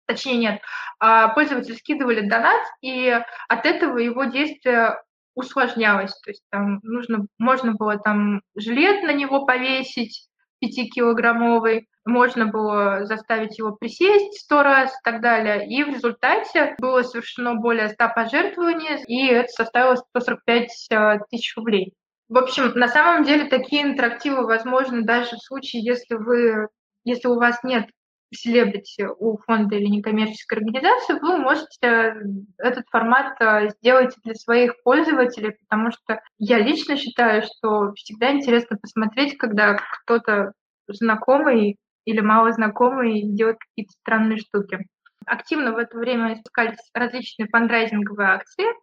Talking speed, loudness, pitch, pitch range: 130 wpm, -20 LUFS, 235 Hz, 220-255 Hz